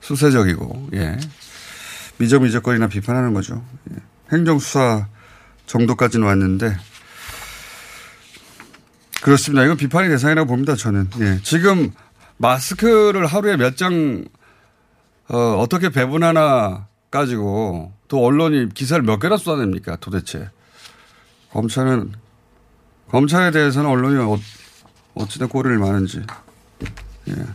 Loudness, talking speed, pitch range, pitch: -17 LUFS, 250 characters per minute, 105-145 Hz, 125 Hz